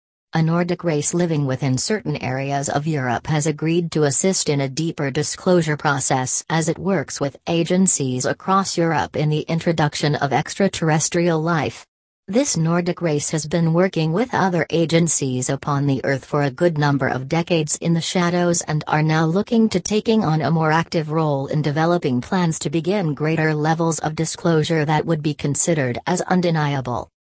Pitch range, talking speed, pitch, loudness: 145-170 Hz, 170 wpm, 160 Hz, -19 LUFS